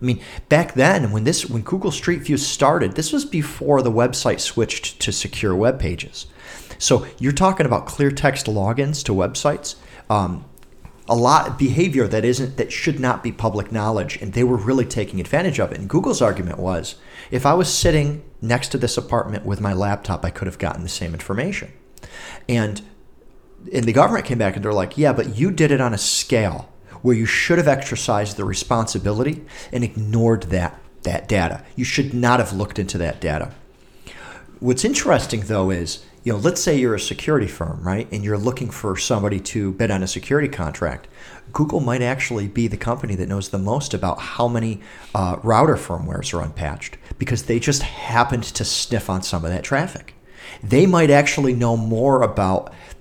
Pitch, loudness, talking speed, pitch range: 120 Hz, -20 LUFS, 190 wpm, 100-135 Hz